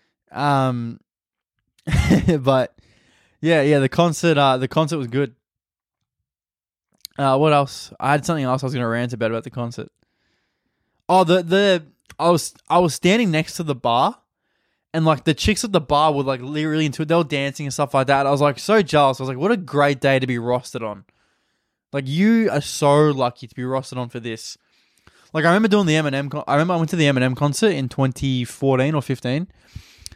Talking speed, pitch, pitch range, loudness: 205 wpm, 140 Hz, 130-160 Hz, -19 LUFS